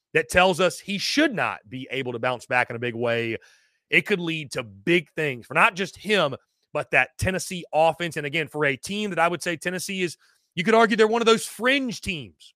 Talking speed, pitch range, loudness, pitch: 235 wpm, 135-205 Hz, -23 LUFS, 175 Hz